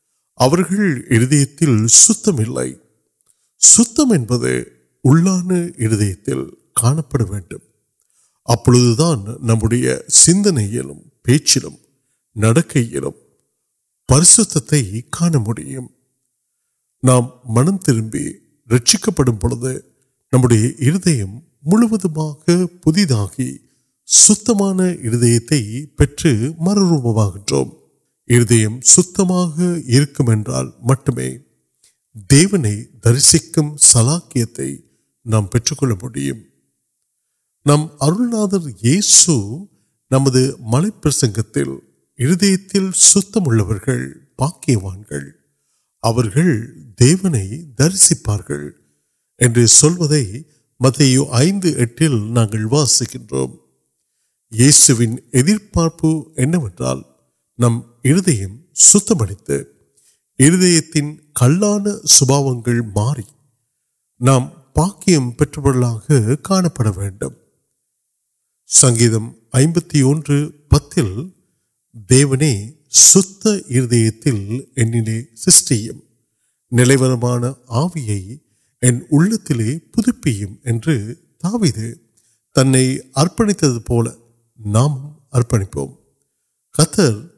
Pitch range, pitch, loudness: 115-155 Hz, 130 Hz, -14 LUFS